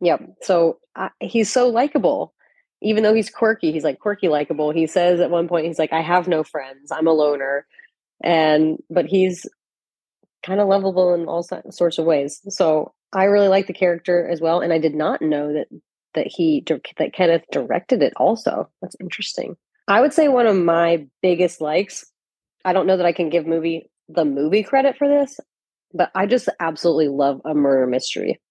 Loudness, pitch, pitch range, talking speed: -19 LUFS, 170 Hz, 155-195 Hz, 195 wpm